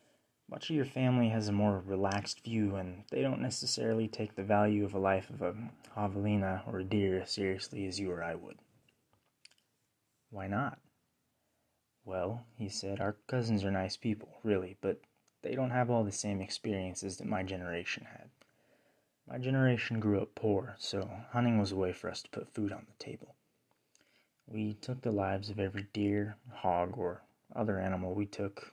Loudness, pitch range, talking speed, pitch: -35 LUFS, 95-115 Hz, 180 wpm, 105 Hz